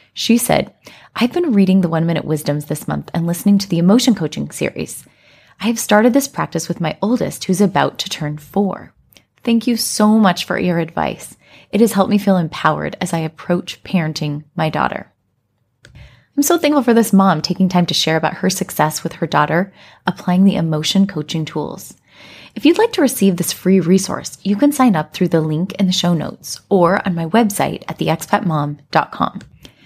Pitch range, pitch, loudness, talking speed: 160-205 Hz, 185 Hz, -16 LUFS, 195 wpm